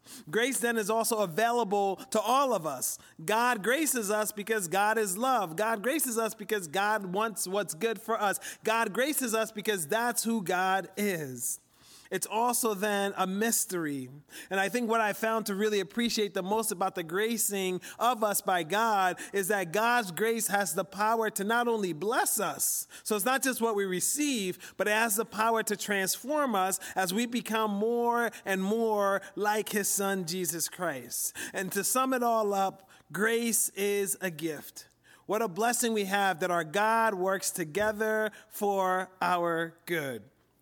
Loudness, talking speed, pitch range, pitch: -29 LUFS, 175 wpm, 190-225 Hz, 210 Hz